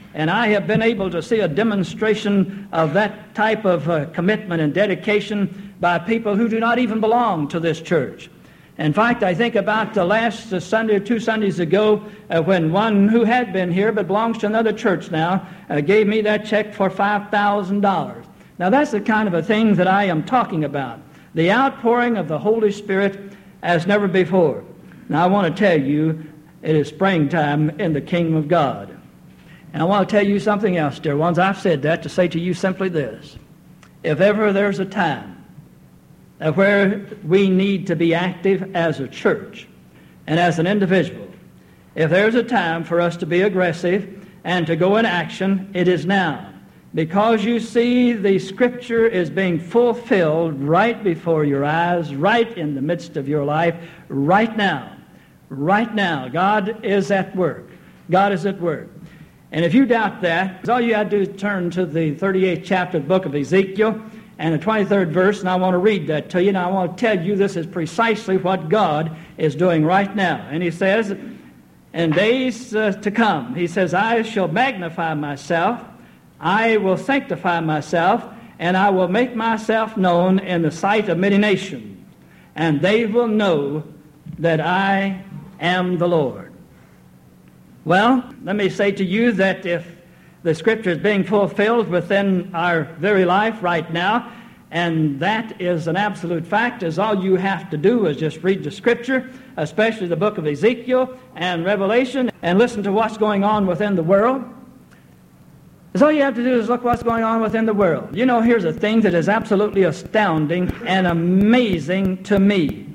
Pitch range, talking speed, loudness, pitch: 170-215 Hz, 185 wpm, -19 LUFS, 190 Hz